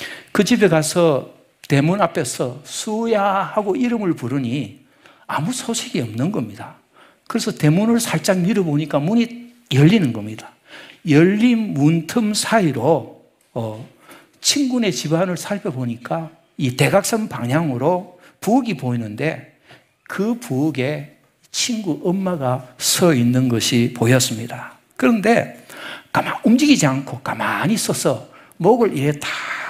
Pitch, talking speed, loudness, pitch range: 165 Hz, 255 characters per minute, -19 LUFS, 135-215 Hz